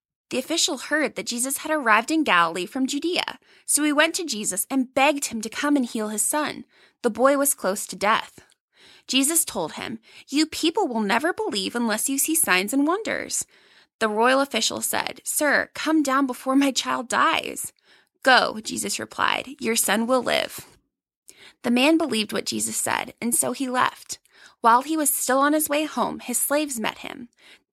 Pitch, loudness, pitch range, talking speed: 270 Hz, -22 LUFS, 230-300 Hz, 185 wpm